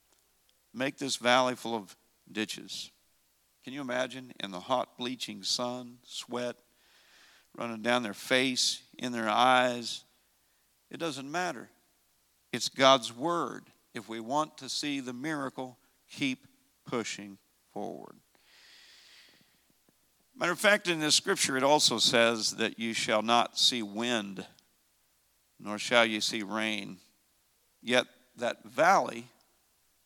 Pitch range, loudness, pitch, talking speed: 110-130 Hz, -29 LUFS, 120 Hz, 120 wpm